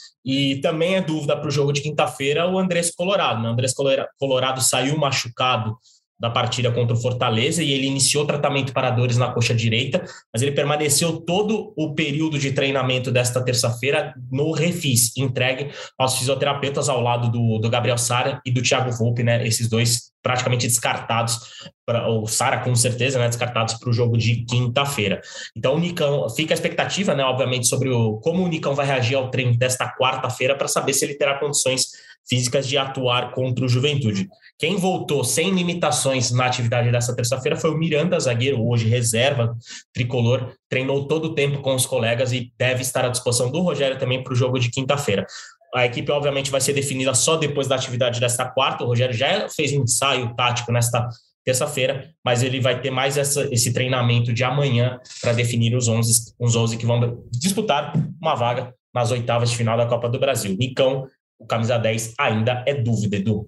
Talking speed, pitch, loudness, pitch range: 185 wpm, 130 Hz, -21 LUFS, 120-140 Hz